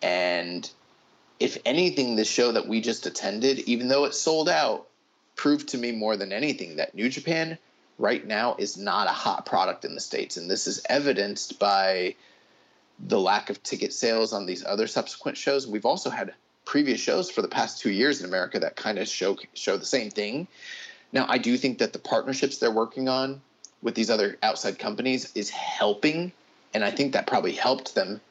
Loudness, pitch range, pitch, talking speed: -26 LUFS, 105-140 Hz, 120 Hz, 195 wpm